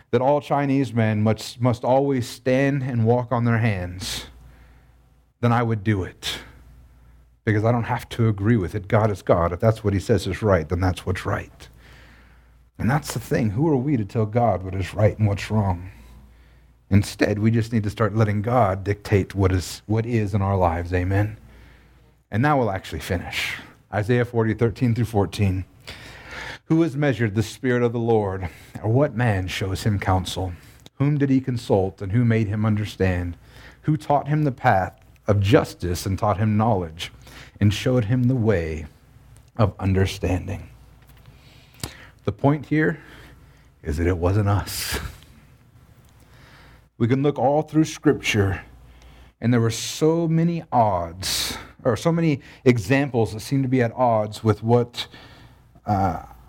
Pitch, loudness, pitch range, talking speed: 110 Hz, -22 LUFS, 95-125 Hz, 165 wpm